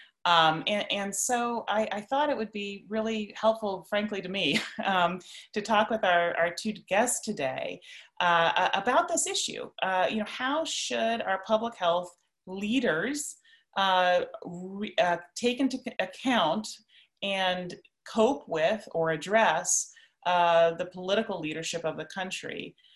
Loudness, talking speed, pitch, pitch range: -28 LUFS, 145 wpm, 205 Hz, 180-225 Hz